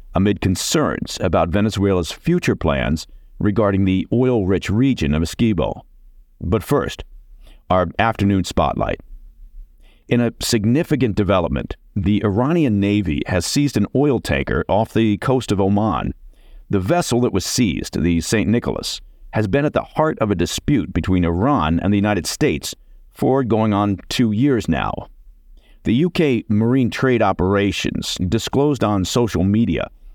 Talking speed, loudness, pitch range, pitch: 140 wpm, -19 LUFS, 85-120 Hz, 100 Hz